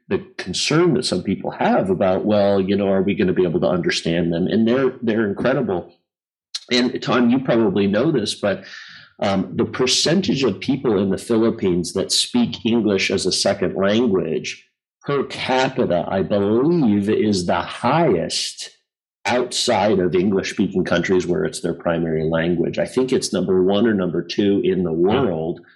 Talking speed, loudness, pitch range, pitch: 170 wpm, -19 LUFS, 95-120 Hz, 105 Hz